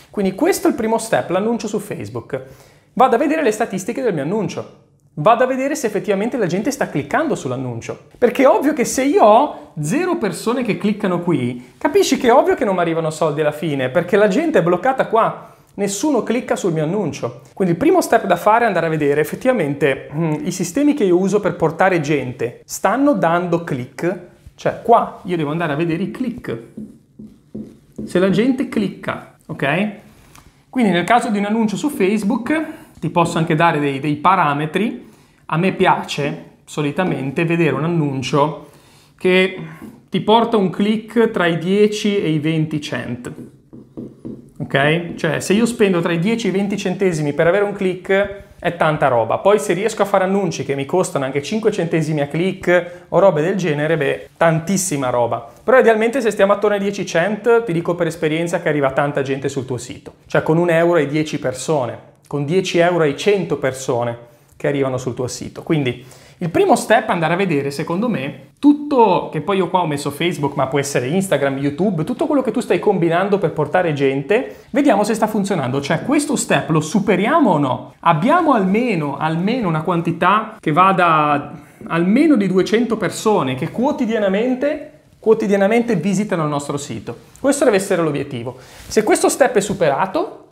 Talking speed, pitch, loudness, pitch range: 185 wpm, 180 Hz, -17 LUFS, 150-215 Hz